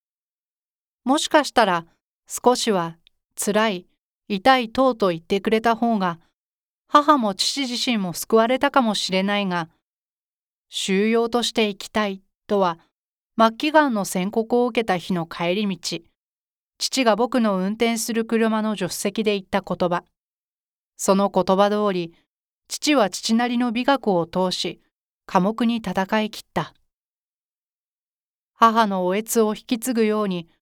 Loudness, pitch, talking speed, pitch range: -21 LUFS, 215 Hz, 240 characters per minute, 190-235 Hz